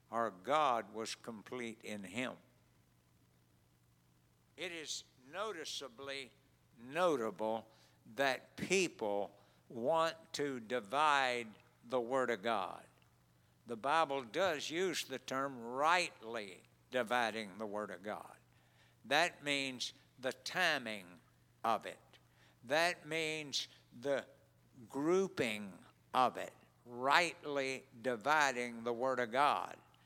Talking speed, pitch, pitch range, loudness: 100 wpm, 125 Hz, 105-140 Hz, -37 LUFS